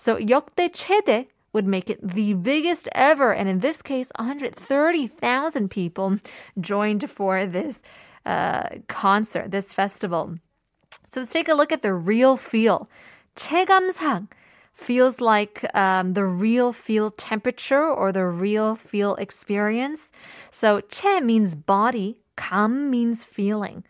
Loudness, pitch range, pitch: -22 LUFS, 200-270 Hz, 220 Hz